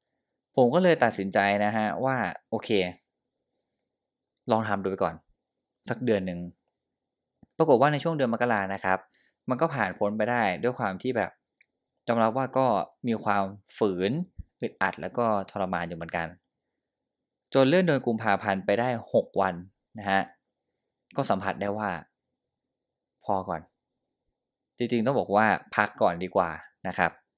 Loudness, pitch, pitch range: -27 LUFS, 105 Hz, 95-120 Hz